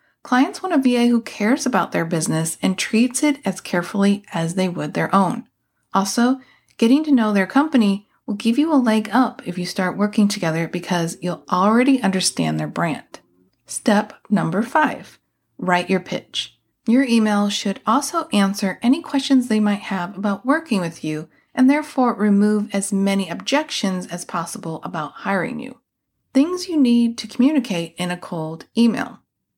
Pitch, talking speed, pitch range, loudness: 210 Hz, 165 wpm, 180-250 Hz, -20 LUFS